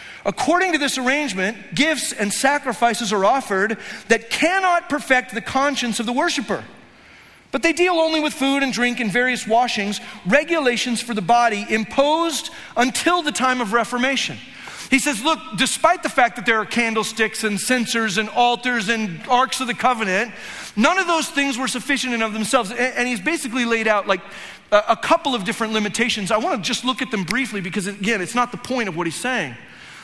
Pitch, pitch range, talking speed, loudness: 245 Hz, 220-270 Hz, 190 wpm, -20 LUFS